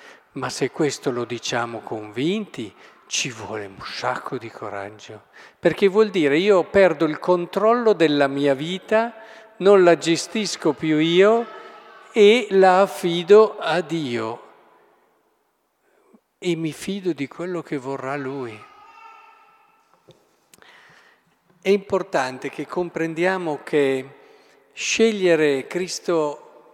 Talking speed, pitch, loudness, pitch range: 105 wpm, 180 Hz, -20 LUFS, 150-215 Hz